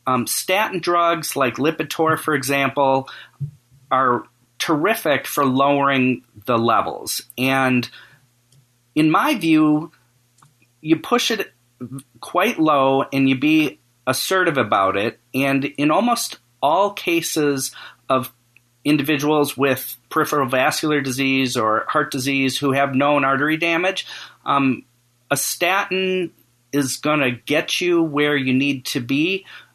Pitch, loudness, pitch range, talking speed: 140 Hz, -19 LUFS, 130-155 Hz, 120 wpm